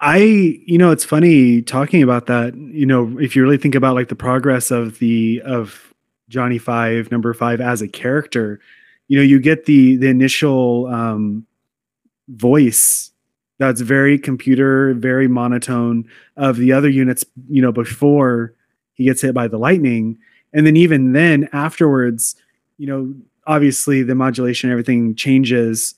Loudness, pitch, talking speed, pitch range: -15 LUFS, 130 Hz, 155 wpm, 120-140 Hz